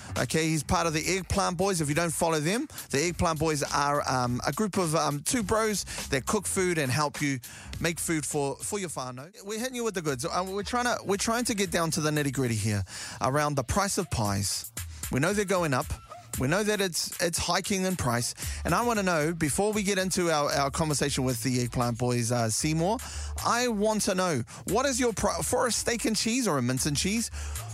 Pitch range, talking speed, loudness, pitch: 130-200 Hz, 235 wpm, -28 LUFS, 160 Hz